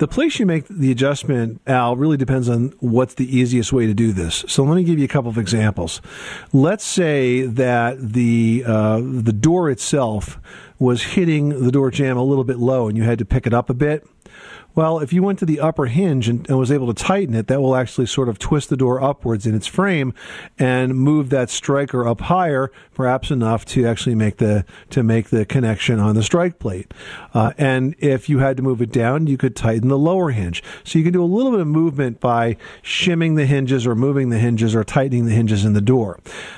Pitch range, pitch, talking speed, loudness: 115-145 Hz, 130 Hz, 225 wpm, -18 LUFS